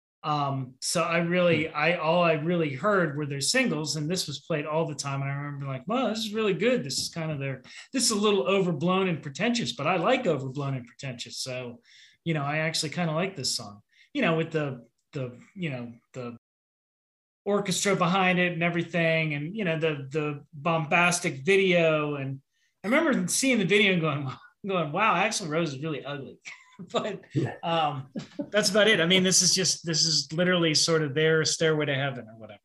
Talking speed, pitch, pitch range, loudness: 210 wpm, 160 Hz, 145-185 Hz, -26 LUFS